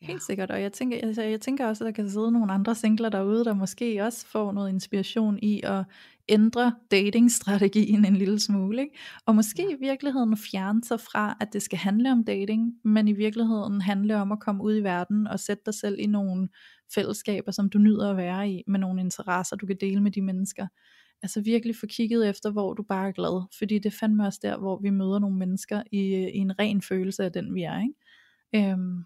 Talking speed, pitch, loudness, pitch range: 220 wpm, 210 Hz, -26 LUFS, 195-220 Hz